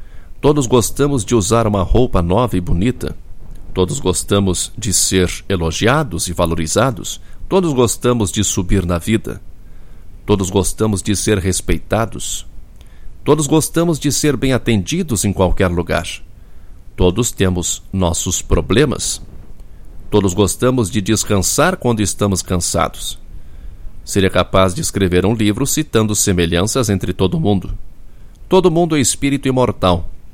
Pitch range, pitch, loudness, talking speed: 90-120 Hz, 100 Hz, -16 LUFS, 125 wpm